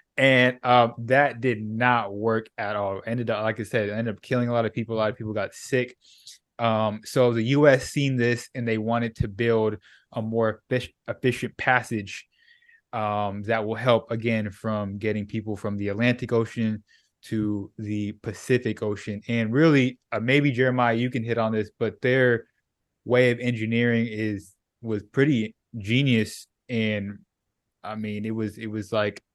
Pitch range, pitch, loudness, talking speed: 105-125 Hz, 115 Hz, -25 LUFS, 170 wpm